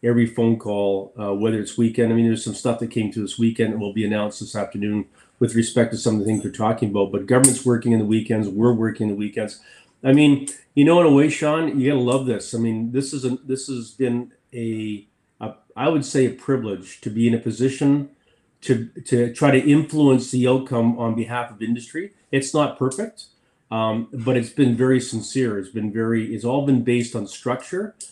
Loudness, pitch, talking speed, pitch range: -21 LUFS, 120 Hz, 220 wpm, 110-130 Hz